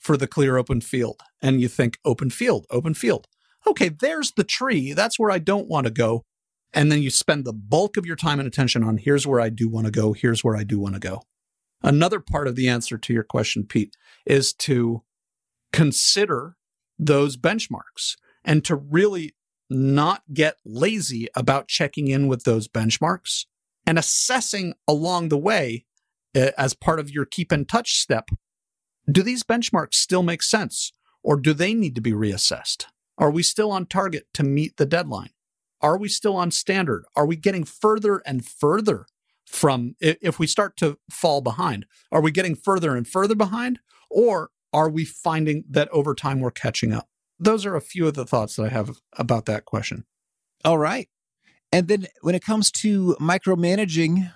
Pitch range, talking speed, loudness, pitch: 130-190 Hz, 185 wpm, -22 LUFS, 155 Hz